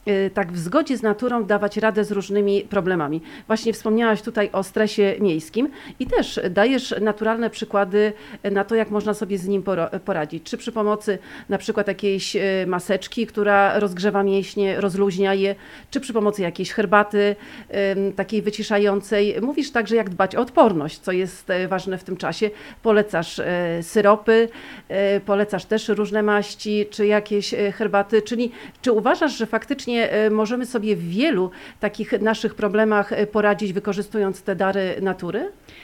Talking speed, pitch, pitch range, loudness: 145 wpm, 205 Hz, 195-220 Hz, -21 LUFS